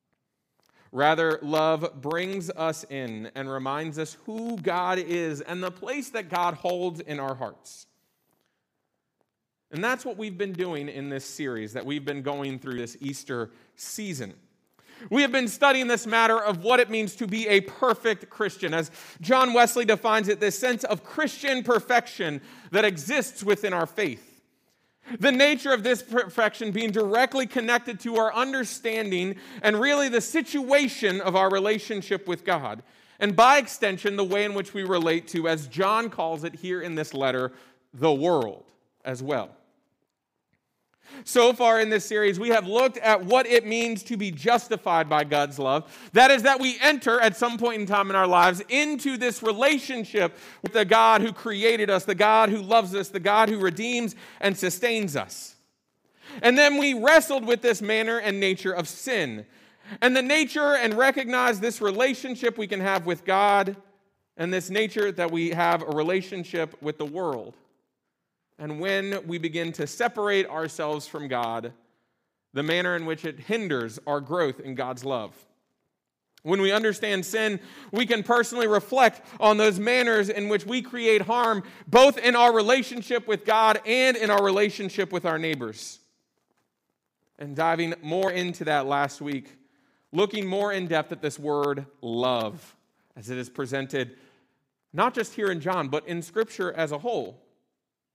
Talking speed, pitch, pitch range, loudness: 170 wpm, 200 Hz, 160-230 Hz, -24 LUFS